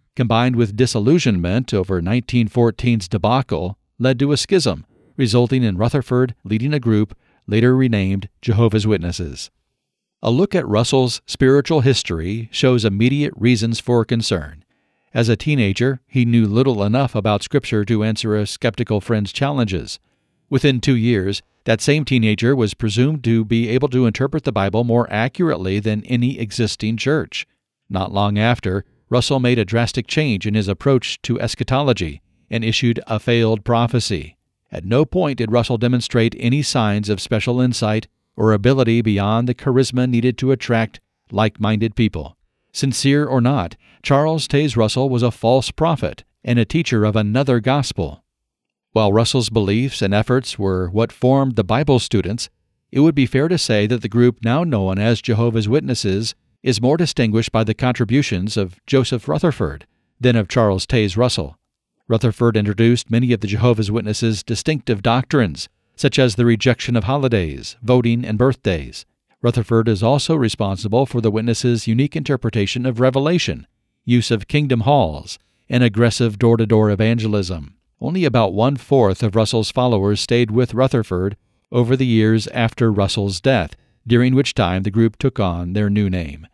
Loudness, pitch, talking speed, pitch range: -18 LUFS, 115 Hz, 155 wpm, 105-130 Hz